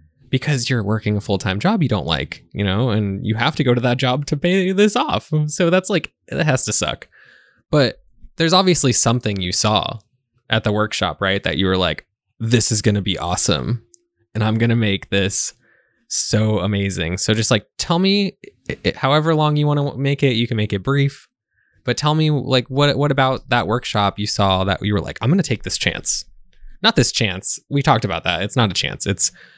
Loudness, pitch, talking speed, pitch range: -18 LUFS, 115 Hz, 220 wpm, 100-140 Hz